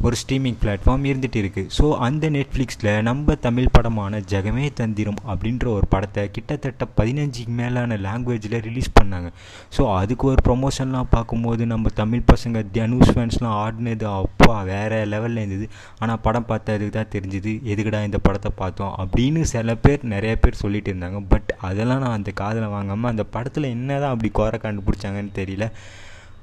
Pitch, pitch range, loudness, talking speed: 110 Hz, 100-120 Hz, -22 LUFS, 155 wpm